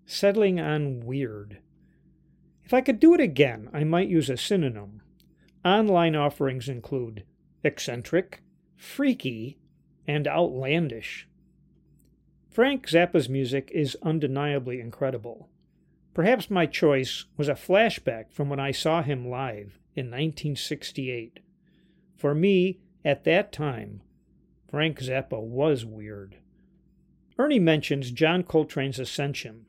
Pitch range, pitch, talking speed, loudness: 130-175 Hz, 150 Hz, 110 wpm, -26 LUFS